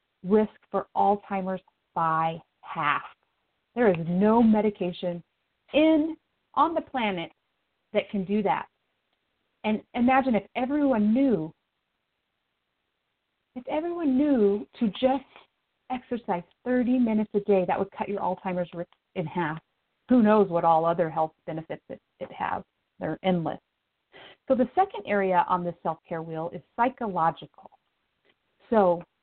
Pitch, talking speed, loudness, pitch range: 205 Hz, 130 wpm, -26 LUFS, 175-250 Hz